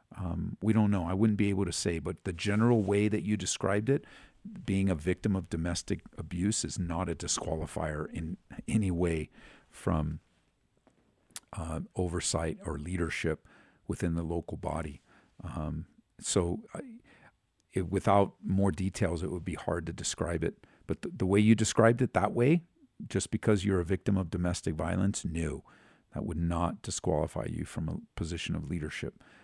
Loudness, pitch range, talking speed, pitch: -32 LUFS, 85-105 Hz, 165 wpm, 95 Hz